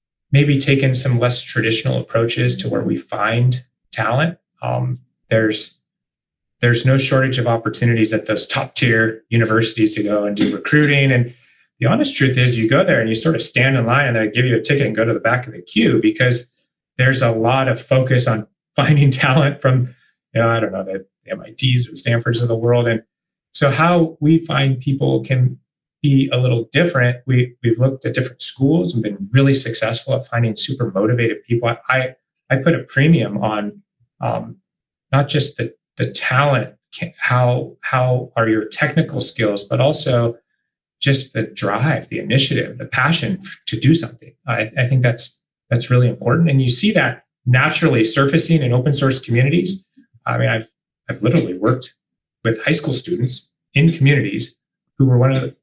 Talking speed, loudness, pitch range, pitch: 185 wpm, -17 LUFS, 115-140 Hz, 125 Hz